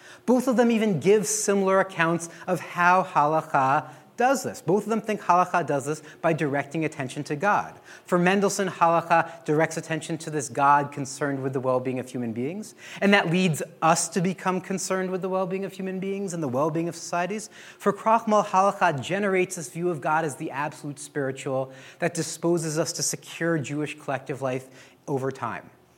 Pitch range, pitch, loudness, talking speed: 150-190 Hz, 165 Hz, -25 LUFS, 190 wpm